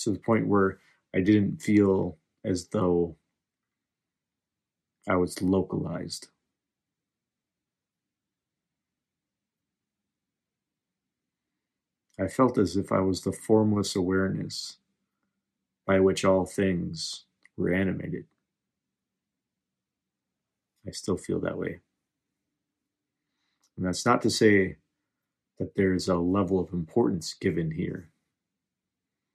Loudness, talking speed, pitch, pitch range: -27 LUFS, 95 wpm, 95 Hz, 90-100 Hz